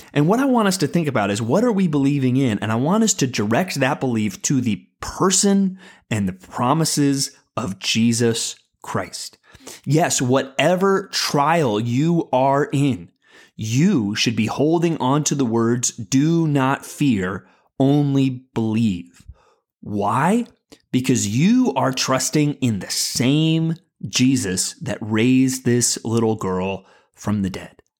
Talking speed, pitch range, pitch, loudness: 145 wpm, 115-155 Hz, 135 Hz, -19 LUFS